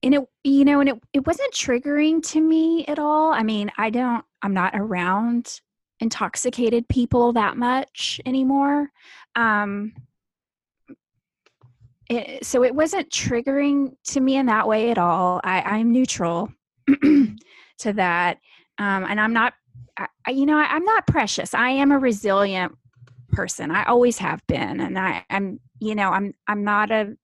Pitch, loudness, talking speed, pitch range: 235 Hz, -21 LUFS, 160 wpm, 200-275 Hz